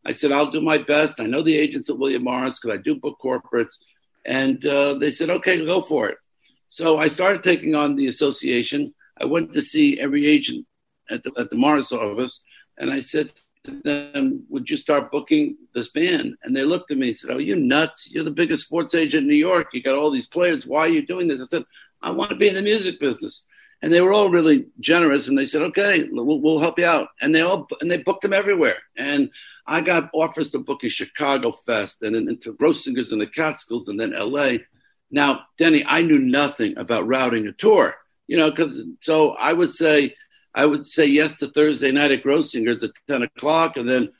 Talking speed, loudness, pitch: 225 wpm, -20 LUFS, 165 Hz